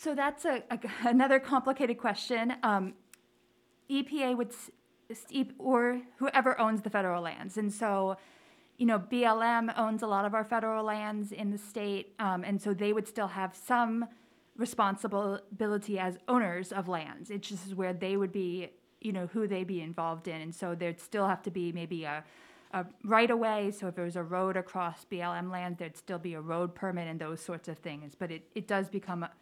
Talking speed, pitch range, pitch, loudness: 195 wpm, 180-230 Hz, 200 Hz, -33 LUFS